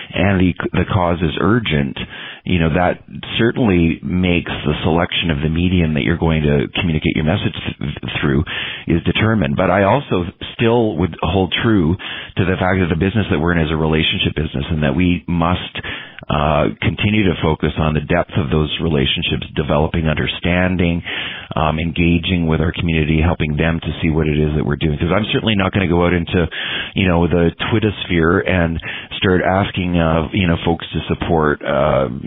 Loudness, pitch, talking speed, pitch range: -17 LUFS, 85 Hz, 190 wpm, 80-95 Hz